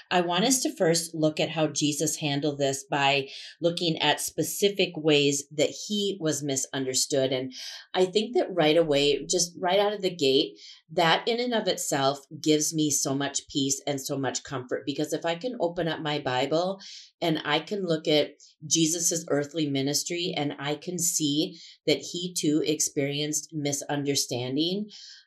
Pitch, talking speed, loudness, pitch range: 155 Hz, 170 wpm, -26 LUFS, 145-175 Hz